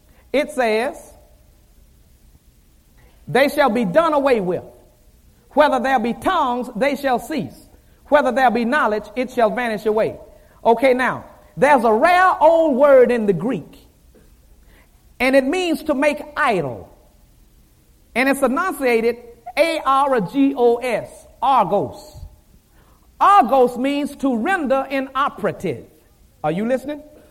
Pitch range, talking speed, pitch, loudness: 225-290 Hz, 125 wpm, 260 Hz, -18 LUFS